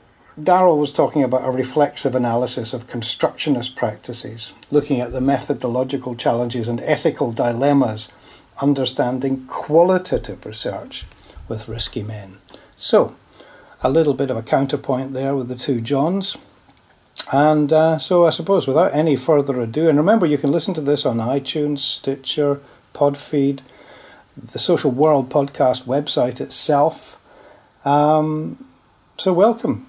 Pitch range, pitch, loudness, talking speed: 125-155 Hz, 140 Hz, -19 LUFS, 130 wpm